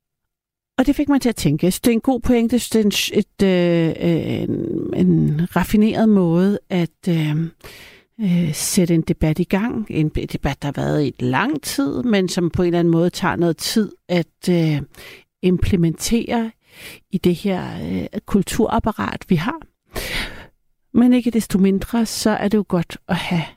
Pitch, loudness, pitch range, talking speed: 185 Hz, -19 LUFS, 170-225 Hz, 180 wpm